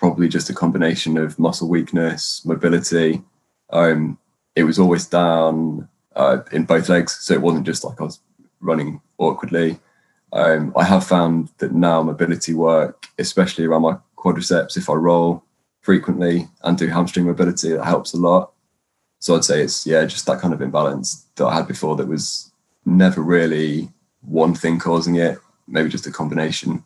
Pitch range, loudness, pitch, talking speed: 80-85 Hz, -18 LUFS, 85 Hz, 170 wpm